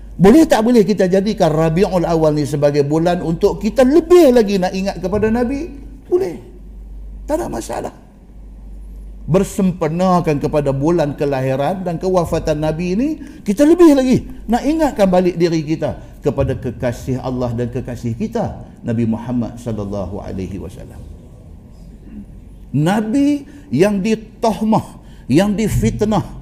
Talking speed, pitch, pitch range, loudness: 125 wpm, 175 Hz, 135-220 Hz, -16 LUFS